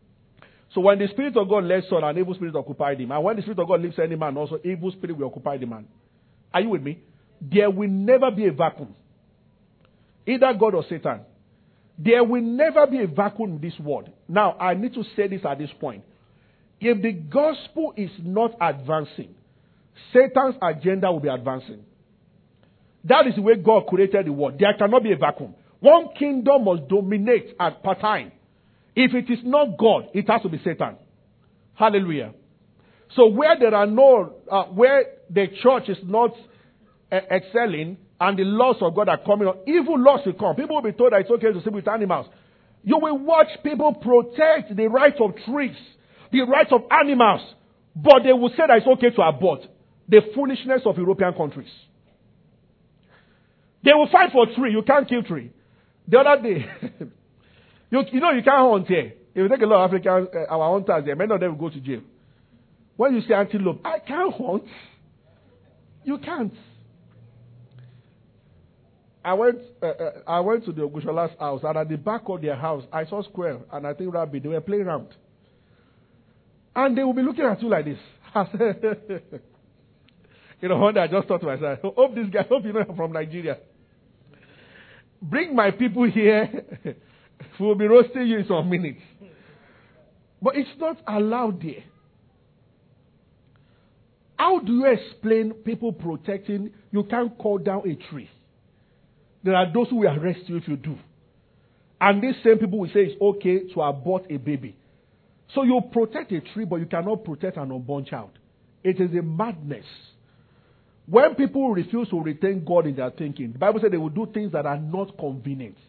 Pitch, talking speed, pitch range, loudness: 200 Hz, 185 wpm, 160-240 Hz, -21 LUFS